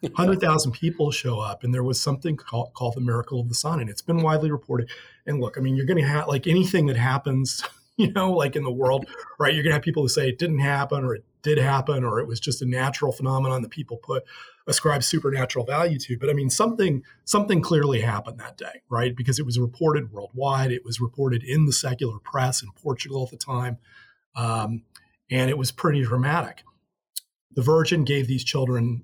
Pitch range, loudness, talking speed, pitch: 125-150 Hz, -24 LUFS, 215 wpm, 135 Hz